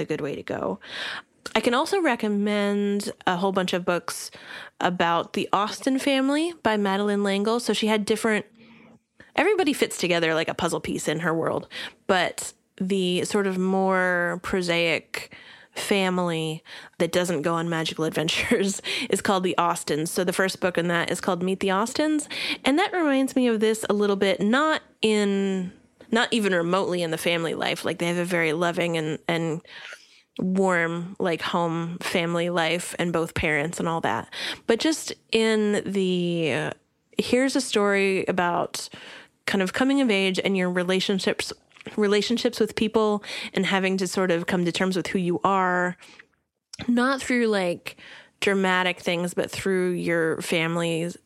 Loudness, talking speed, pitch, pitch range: -24 LUFS, 165 wpm, 190 Hz, 175-220 Hz